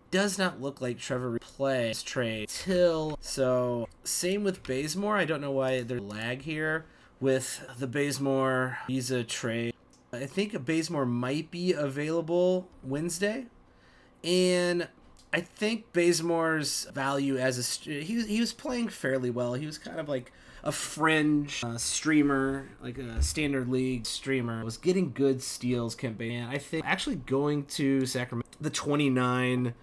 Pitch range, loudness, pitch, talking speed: 125-165 Hz, -30 LUFS, 140 Hz, 150 wpm